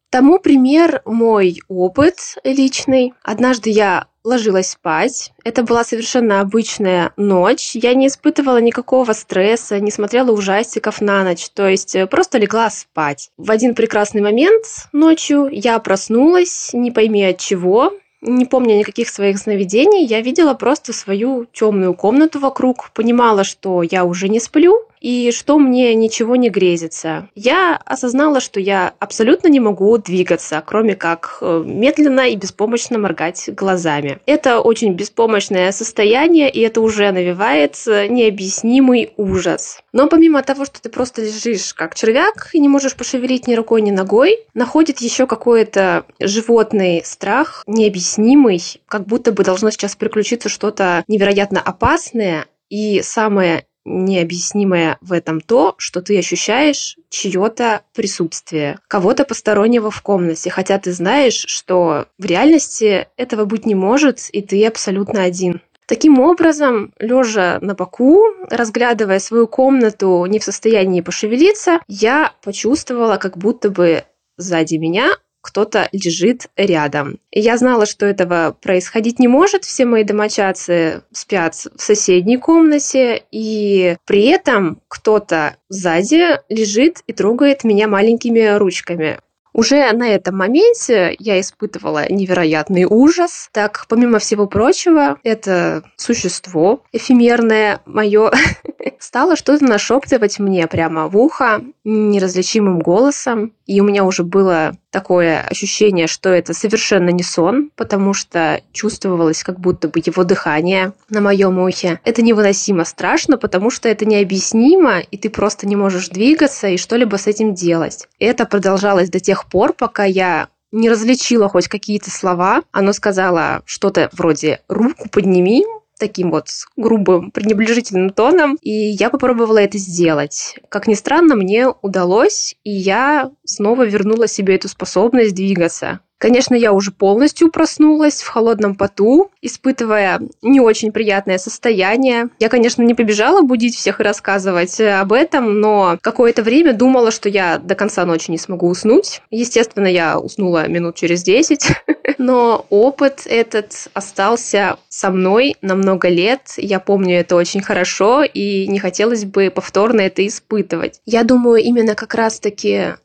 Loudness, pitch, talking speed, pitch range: -14 LUFS, 215 Hz, 135 wpm, 190-245 Hz